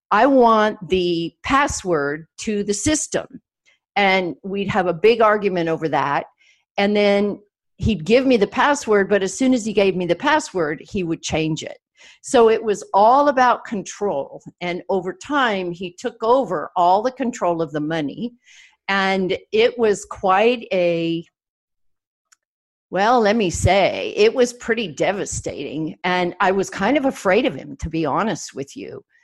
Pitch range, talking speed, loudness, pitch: 175-240 Hz, 160 wpm, -19 LUFS, 200 Hz